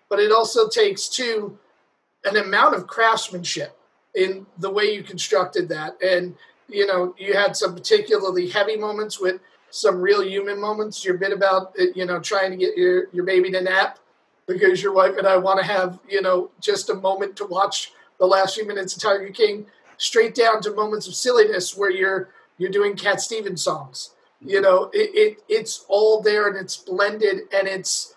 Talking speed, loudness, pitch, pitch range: 190 wpm, -21 LUFS, 200 Hz, 190-220 Hz